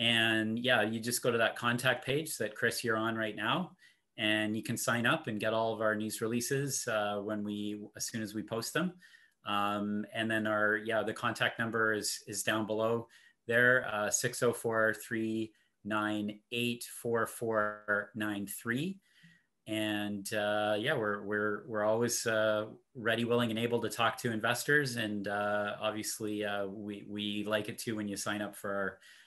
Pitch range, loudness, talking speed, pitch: 105-115 Hz, -33 LUFS, 170 wpm, 110 Hz